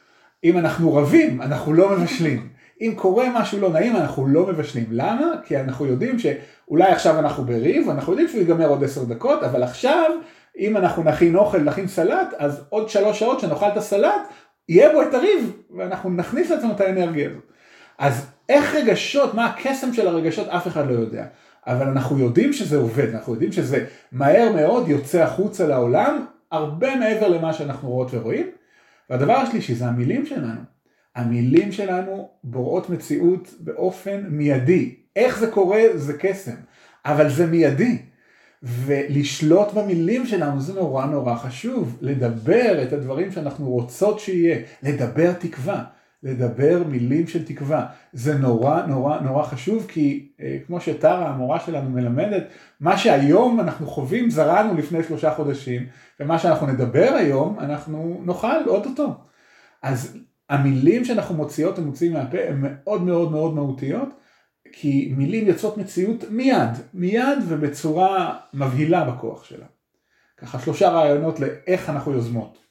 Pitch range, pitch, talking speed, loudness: 140-205 Hz, 160 Hz, 145 wpm, -20 LUFS